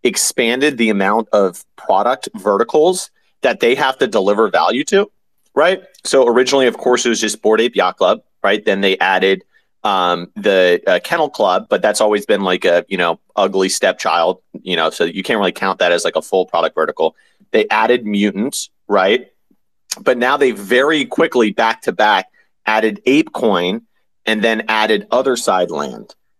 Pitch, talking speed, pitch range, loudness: 110 Hz, 180 wpm, 100-125 Hz, -15 LUFS